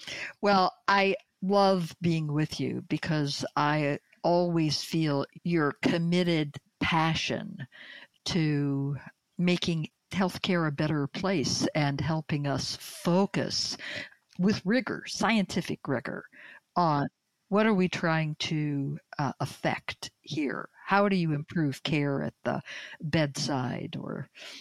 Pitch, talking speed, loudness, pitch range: 165 Hz, 110 wpm, -29 LUFS, 150-185 Hz